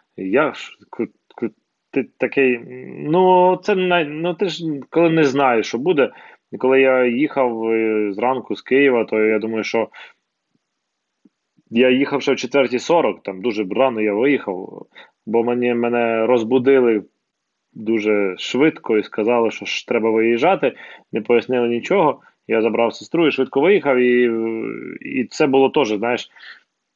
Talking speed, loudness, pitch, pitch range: 130 wpm, -18 LUFS, 125 Hz, 115-140 Hz